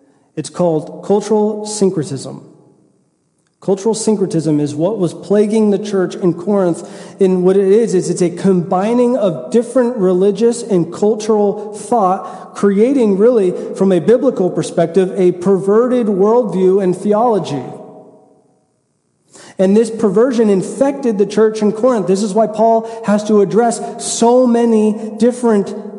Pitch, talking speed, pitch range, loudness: 205 Hz, 130 wpm, 185-225 Hz, -14 LUFS